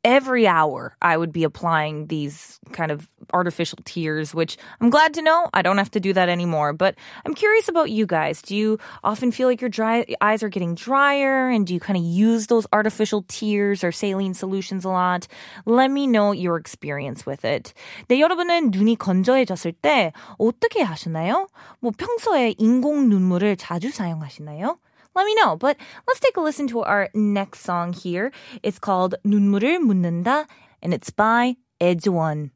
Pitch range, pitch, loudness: 175-250 Hz, 205 Hz, -21 LUFS